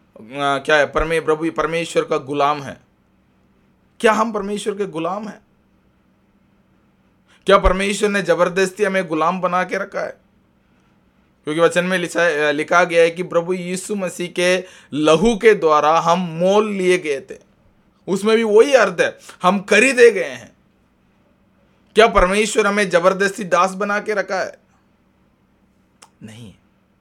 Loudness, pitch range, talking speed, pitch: -17 LUFS, 155-205 Hz, 145 wpm, 180 Hz